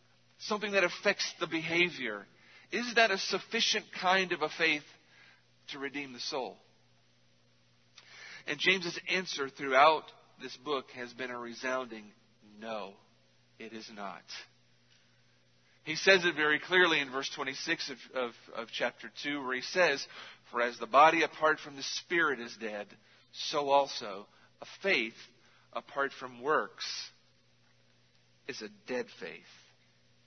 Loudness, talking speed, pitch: -31 LUFS, 135 wpm, 125 Hz